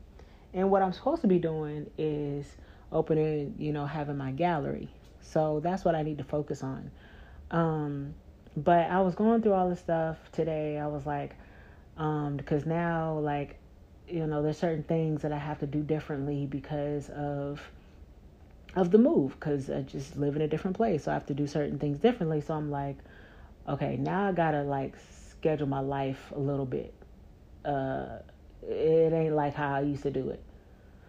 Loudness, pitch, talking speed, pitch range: -30 LUFS, 150 Hz, 185 wpm, 140-160 Hz